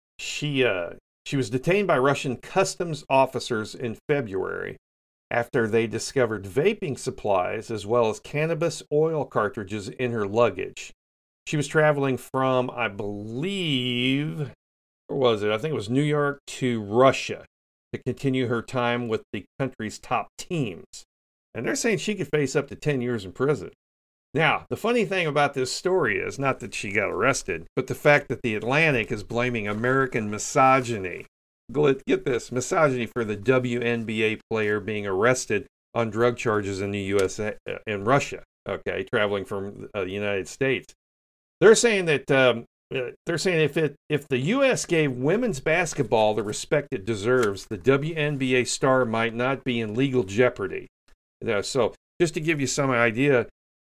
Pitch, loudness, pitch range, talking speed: 125 Hz, -24 LUFS, 110-145 Hz, 160 wpm